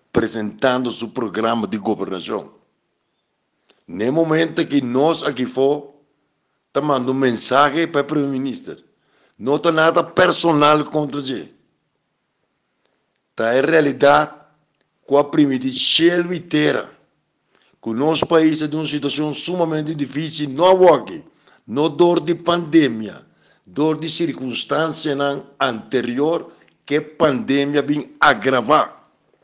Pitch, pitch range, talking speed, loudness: 150 Hz, 140-160 Hz, 120 wpm, -18 LUFS